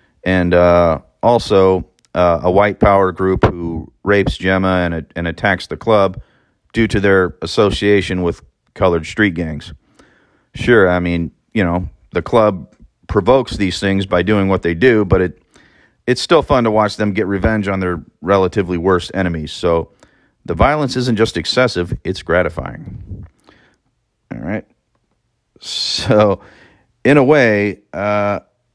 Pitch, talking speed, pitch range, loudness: 95 Hz, 145 wpm, 85-105 Hz, -15 LUFS